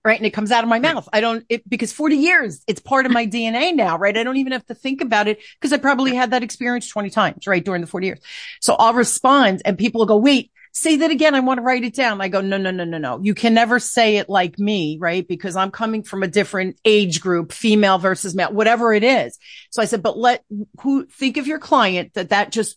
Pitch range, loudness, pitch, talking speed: 195-255 Hz, -18 LUFS, 225 Hz, 265 wpm